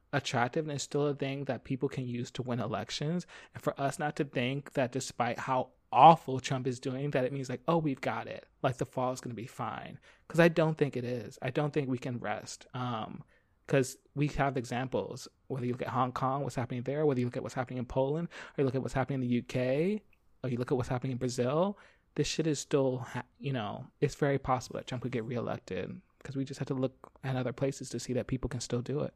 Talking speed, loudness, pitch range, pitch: 255 wpm, -33 LUFS, 125-140 Hz, 130 Hz